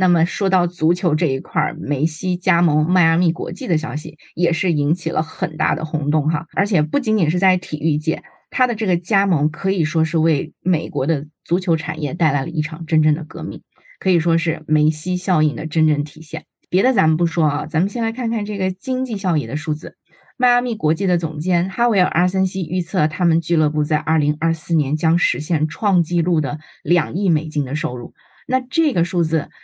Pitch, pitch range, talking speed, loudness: 165 Hz, 155-185 Hz, 300 characters per minute, -19 LUFS